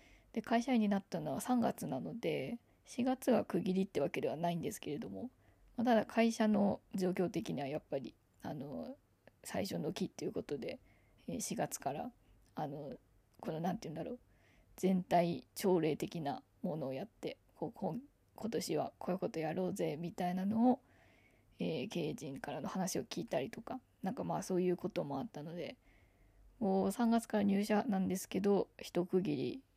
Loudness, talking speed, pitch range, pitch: -38 LUFS, 295 characters per minute, 170-215 Hz, 185 Hz